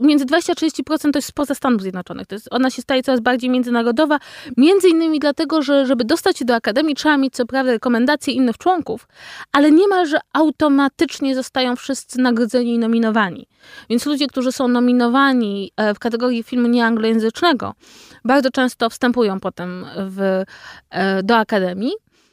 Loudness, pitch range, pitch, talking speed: -17 LUFS, 235-295 Hz, 255 Hz, 155 wpm